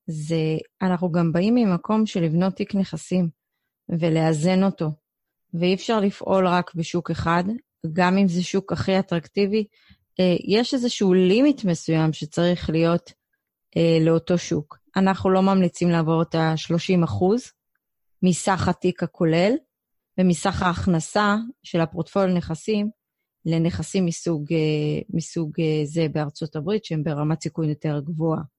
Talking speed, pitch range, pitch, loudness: 120 wpm, 165-195 Hz, 175 Hz, -22 LUFS